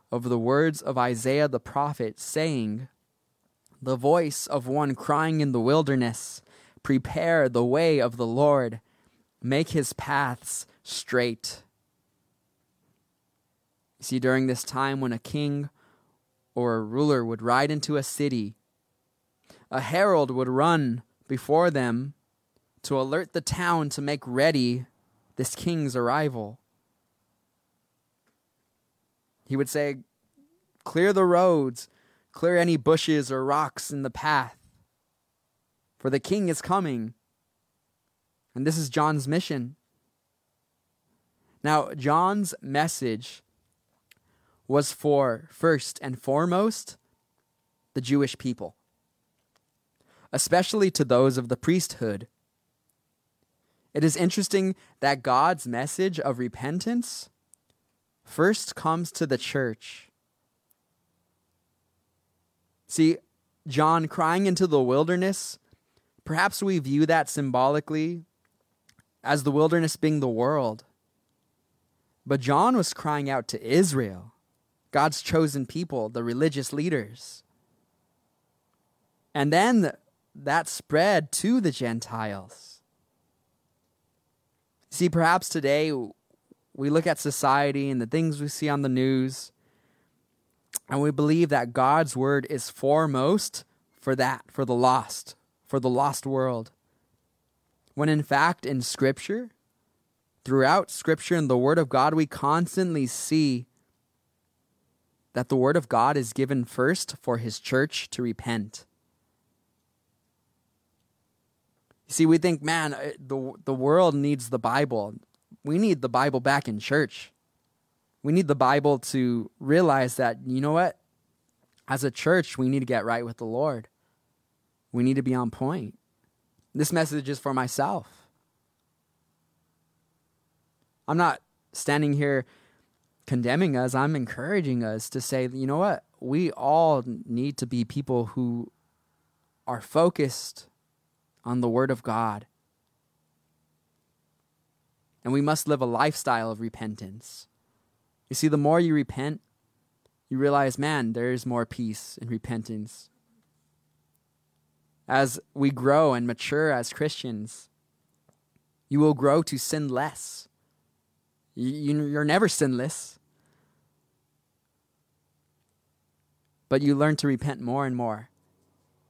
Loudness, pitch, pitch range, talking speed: -25 LUFS, 135 Hz, 120-150 Hz, 120 wpm